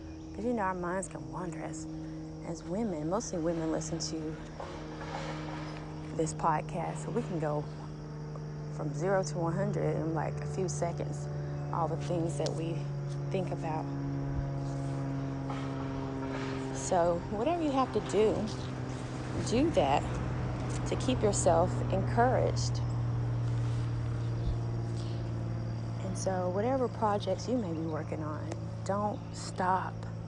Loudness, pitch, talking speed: -33 LUFS, 120 Hz, 115 wpm